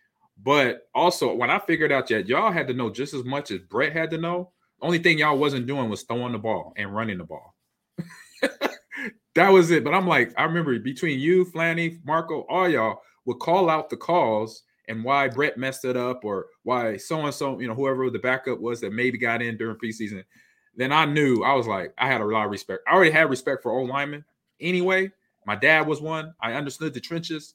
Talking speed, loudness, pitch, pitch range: 225 wpm, -23 LUFS, 145 Hz, 125-165 Hz